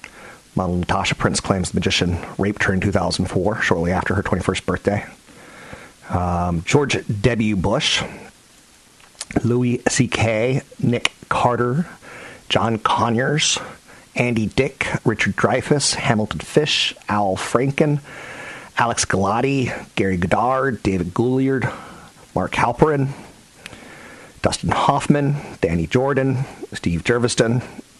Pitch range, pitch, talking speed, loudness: 95-130 Hz, 115 Hz, 100 wpm, -20 LUFS